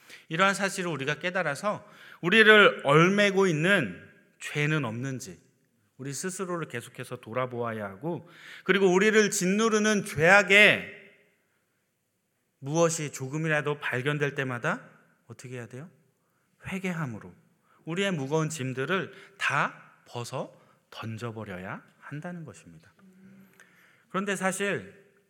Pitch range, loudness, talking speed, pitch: 130-190 Hz, -25 LUFS, 265 characters per minute, 160 Hz